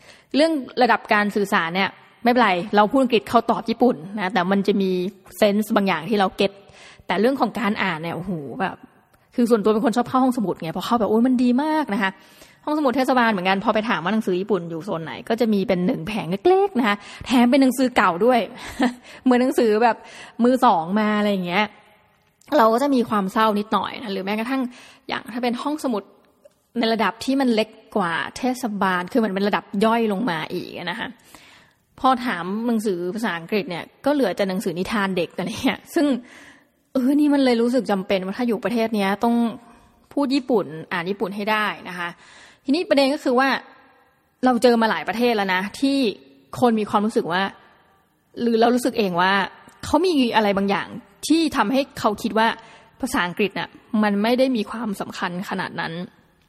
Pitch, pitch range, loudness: 220 Hz, 200-250 Hz, -21 LUFS